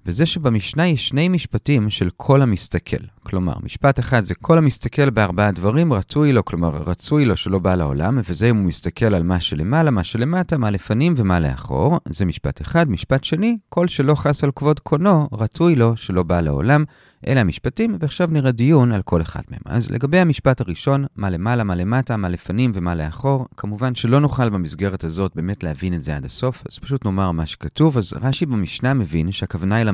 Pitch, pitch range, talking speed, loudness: 120 Hz, 95-145 Hz, 185 wpm, -19 LUFS